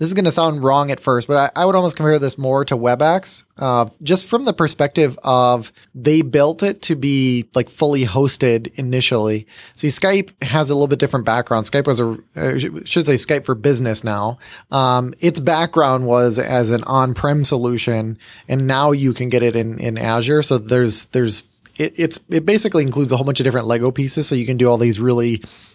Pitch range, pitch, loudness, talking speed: 120-150 Hz, 130 Hz, -16 LUFS, 205 wpm